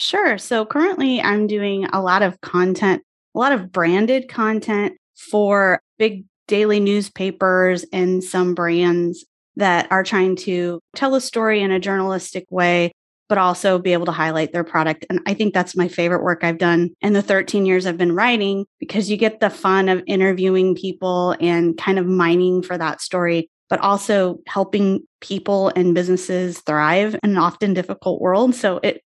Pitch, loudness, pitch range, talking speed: 190 Hz, -18 LUFS, 180-205 Hz, 175 wpm